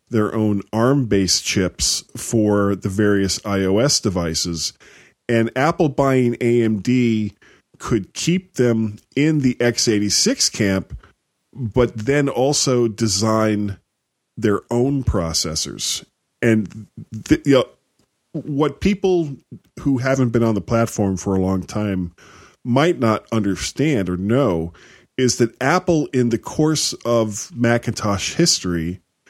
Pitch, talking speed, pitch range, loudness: 115 Hz, 120 wpm, 100-130 Hz, -19 LUFS